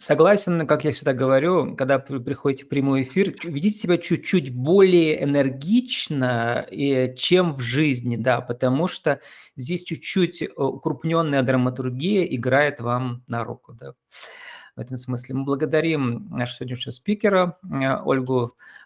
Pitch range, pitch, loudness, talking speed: 130-170 Hz, 140 Hz, -22 LUFS, 125 wpm